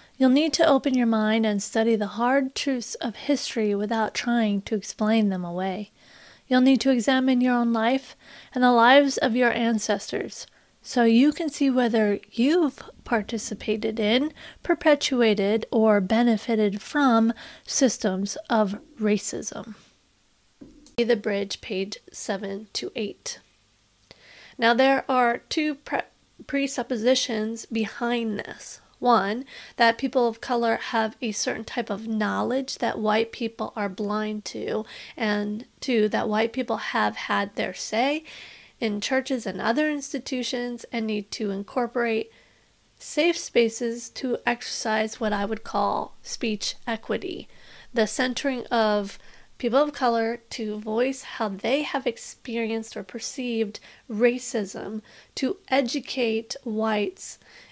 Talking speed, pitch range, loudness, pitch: 130 wpm, 215-255 Hz, -25 LUFS, 230 Hz